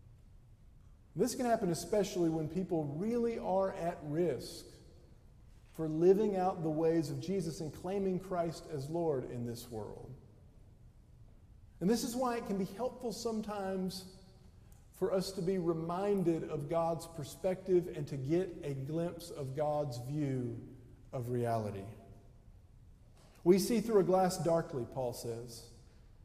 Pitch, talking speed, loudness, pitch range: 160 Hz, 135 wpm, -35 LUFS, 120-185 Hz